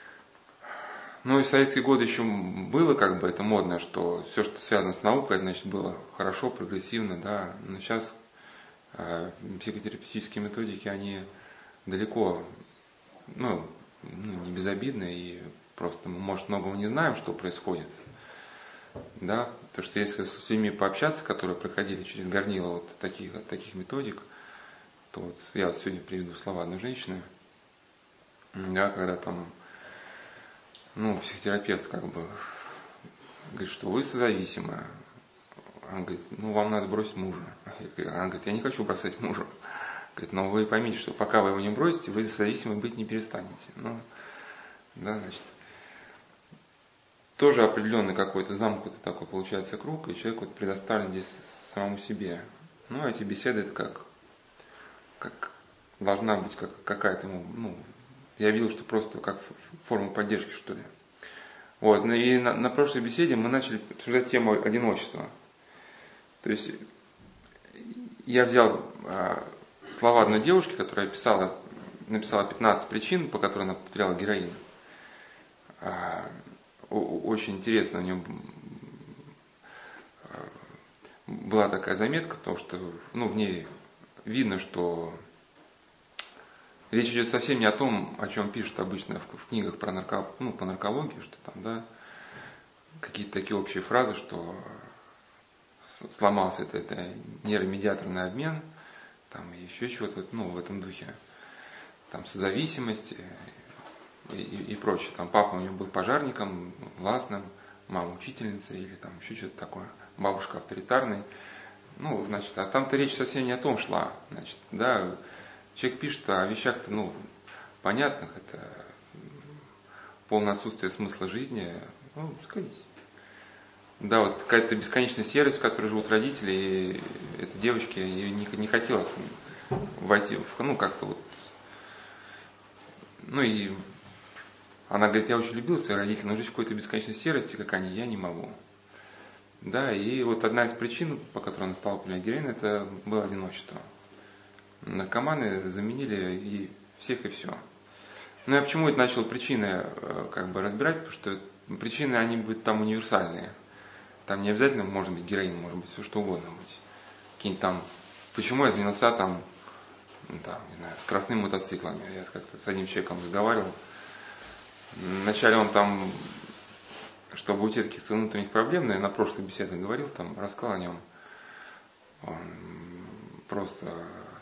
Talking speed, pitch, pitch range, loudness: 140 wpm, 105 Hz, 95-115 Hz, -30 LUFS